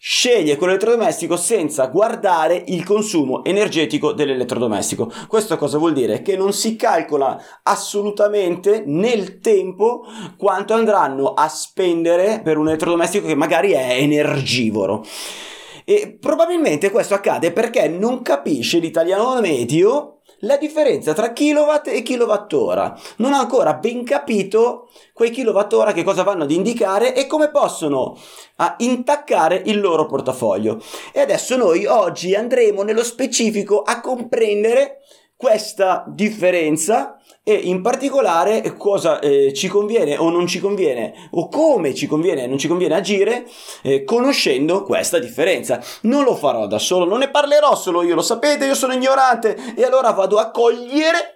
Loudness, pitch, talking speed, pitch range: -17 LUFS, 210 Hz, 140 wpm, 175-255 Hz